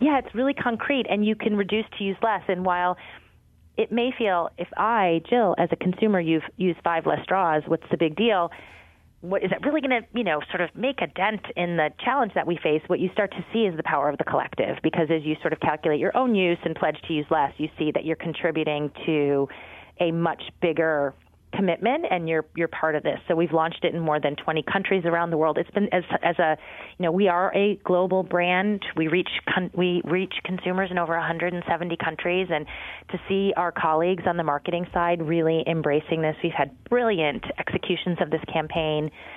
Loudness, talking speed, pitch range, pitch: -24 LUFS, 220 wpm, 160-190 Hz, 175 Hz